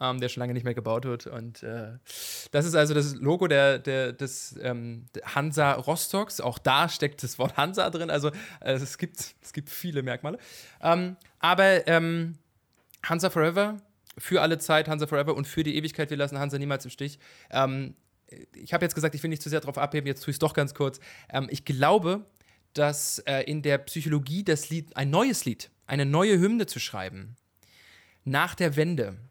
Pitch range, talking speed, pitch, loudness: 130-160 Hz, 195 wpm, 145 Hz, -27 LUFS